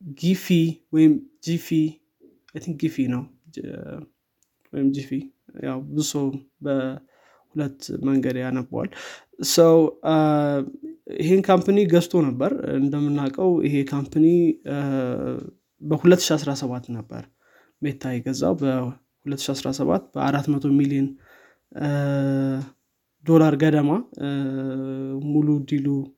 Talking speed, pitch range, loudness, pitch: 65 wpm, 135-160 Hz, -22 LUFS, 140 Hz